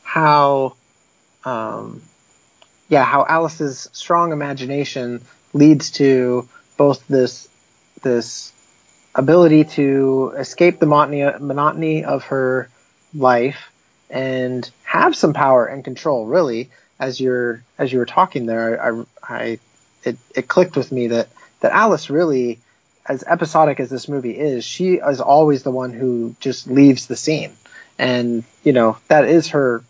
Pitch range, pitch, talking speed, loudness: 125-150 Hz, 135 Hz, 135 wpm, -17 LUFS